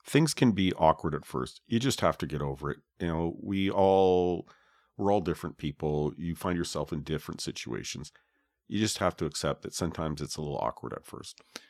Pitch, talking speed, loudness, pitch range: 85 Hz, 205 wpm, -30 LUFS, 75-95 Hz